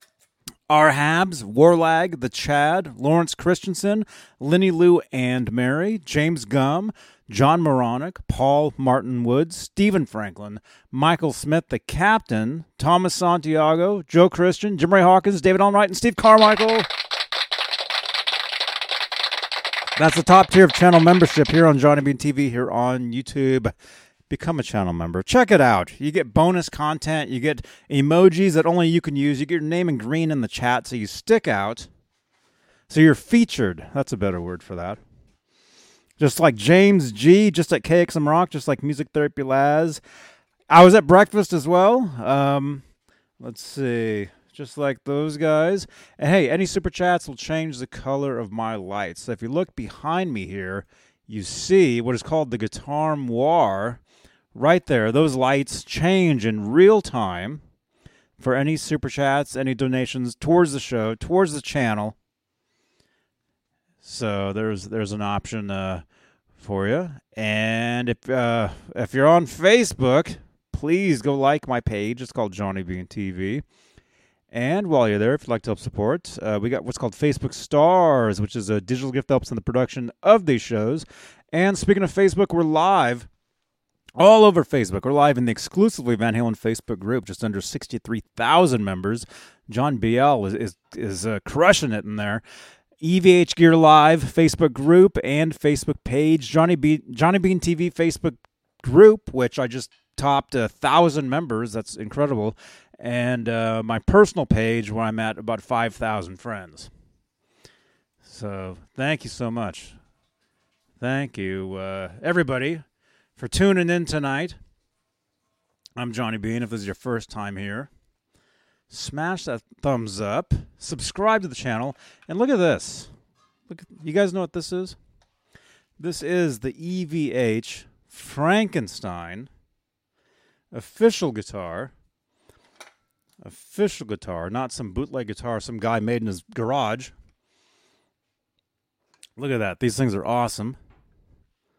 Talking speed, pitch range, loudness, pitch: 150 wpm, 115-165 Hz, -20 LUFS, 135 Hz